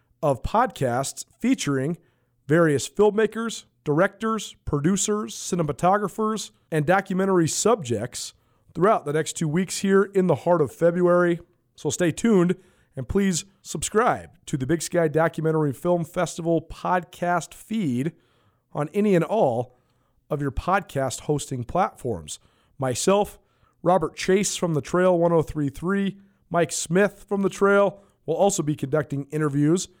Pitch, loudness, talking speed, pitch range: 170 Hz, -23 LUFS, 125 wpm, 145-190 Hz